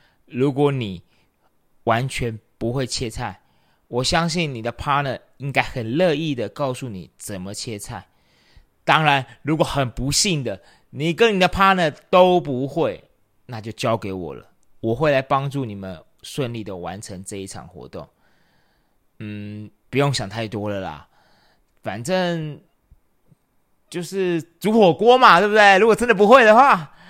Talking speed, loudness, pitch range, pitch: 235 characters per minute, -19 LUFS, 105-165 Hz, 130 Hz